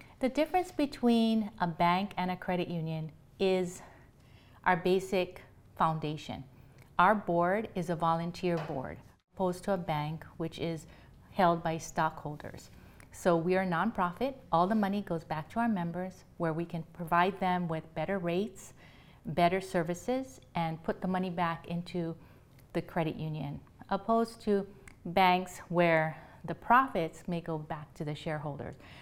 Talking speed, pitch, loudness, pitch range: 150 wpm, 175 Hz, -32 LUFS, 160-190 Hz